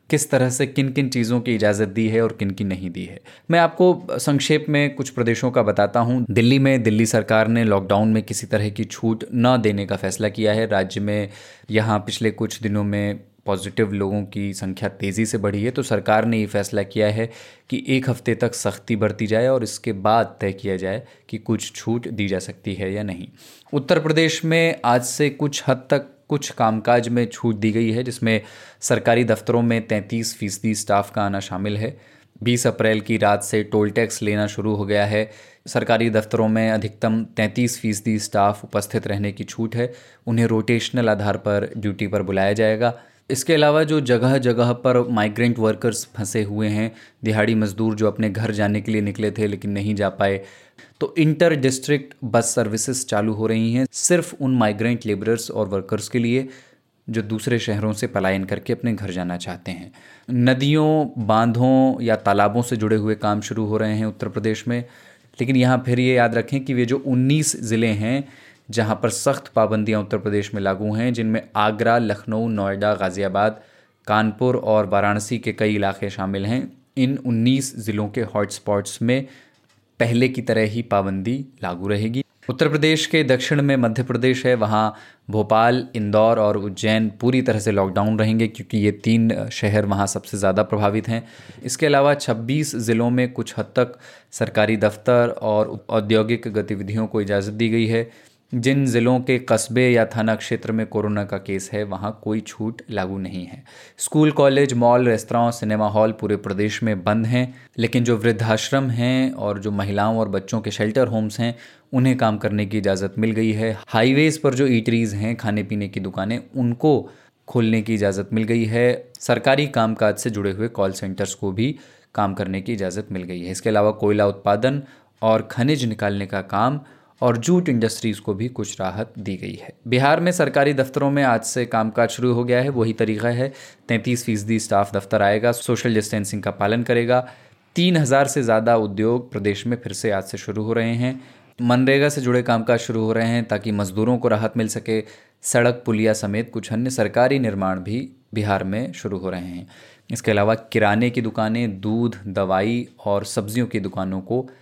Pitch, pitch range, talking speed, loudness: 110 Hz, 105-125 Hz, 190 wpm, -21 LUFS